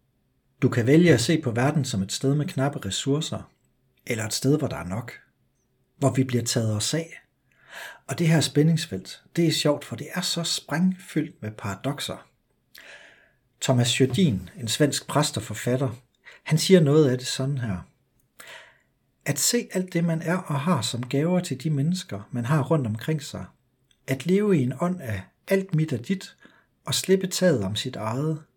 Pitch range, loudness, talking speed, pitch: 125-165 Hz, -24 LUFS, 185 wpm, 140 Hz